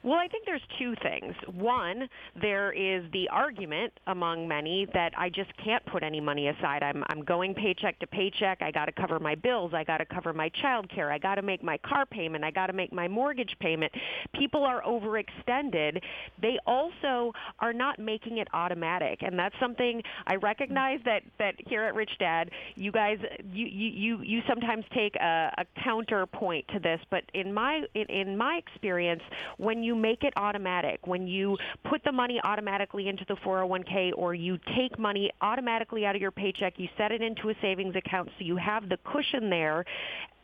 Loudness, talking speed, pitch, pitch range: -30 LUFS, 190 wpm, 200 Hz, 180-230 Hz